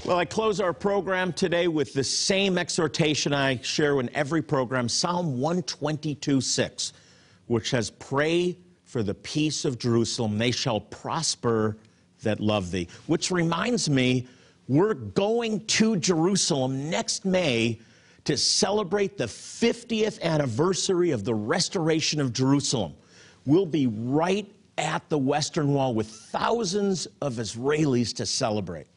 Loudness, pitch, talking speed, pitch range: -25 LUFS, 145 Hz, 135 wpm, 120-180 Hz